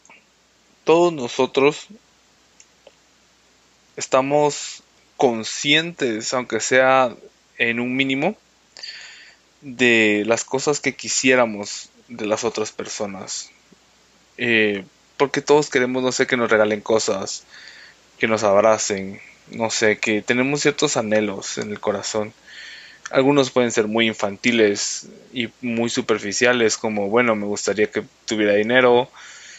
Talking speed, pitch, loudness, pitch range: 110 wpm, 120 Hz, -19 LUFS, 110-130 Hz